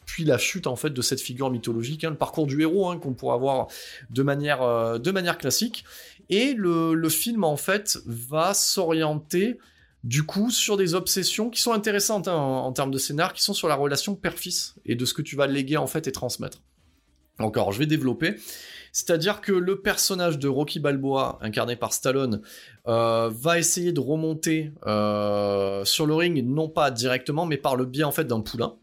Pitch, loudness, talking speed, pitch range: 150 Hz, -24 LUFS, 200 wpm, 125-180 Hz